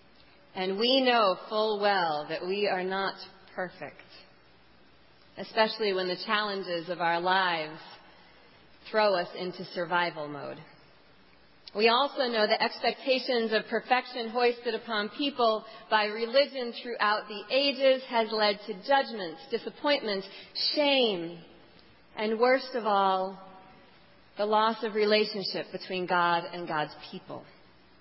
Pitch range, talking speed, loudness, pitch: 185-230 Hz, 120 wpm, -28 LUFS, 210 Hz